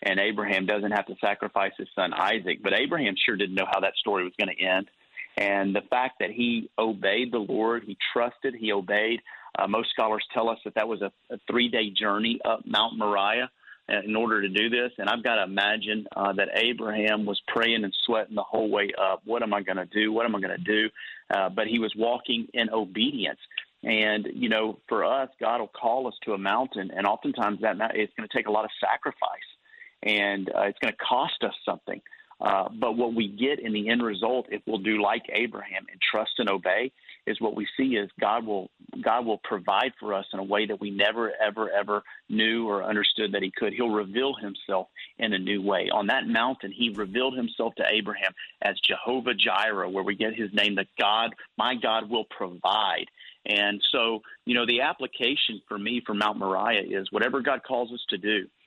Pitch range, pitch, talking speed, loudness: 100-115 Hz, 105 Hz, 215 wpm, -26 LUFS